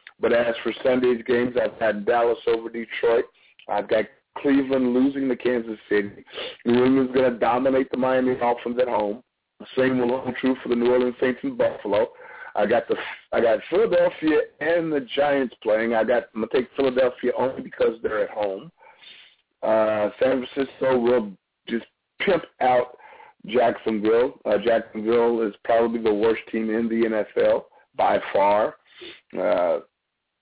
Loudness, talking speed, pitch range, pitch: -23 LUFS, 155 wpm, 115-135 Hz, 125 Hz